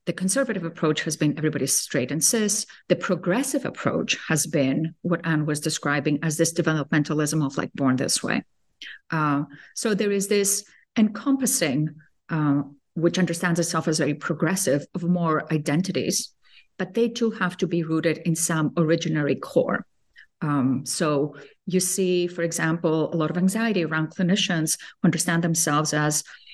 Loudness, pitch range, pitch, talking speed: -24 LUFS, 150-180 Hz, 165 Hz, 155 wpm